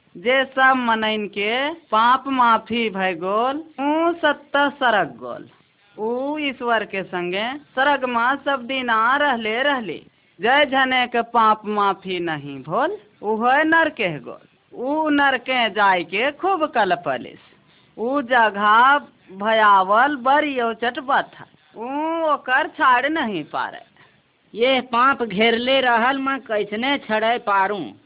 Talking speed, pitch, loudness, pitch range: 125 wpm, 250 Hz, -19 LUFS, 215-280 Hz